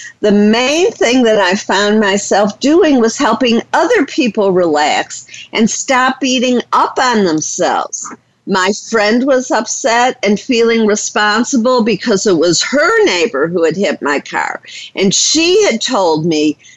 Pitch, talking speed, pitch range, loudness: 225 Hz, 145 wpm, 205-255 Hz, -12 LUFS